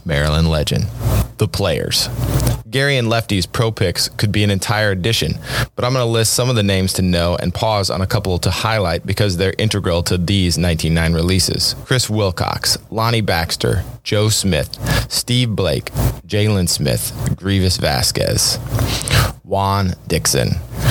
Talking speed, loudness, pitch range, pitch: 150 wpm, -17 LUFS, 95-115 Hz, 105 Hz